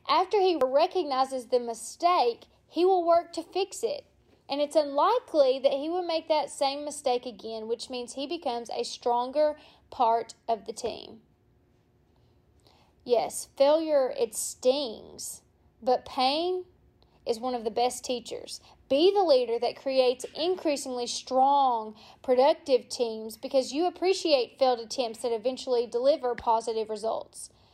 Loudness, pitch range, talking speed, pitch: -27 LUFS, 245-325 Hz, 135 wpm, 270 Hz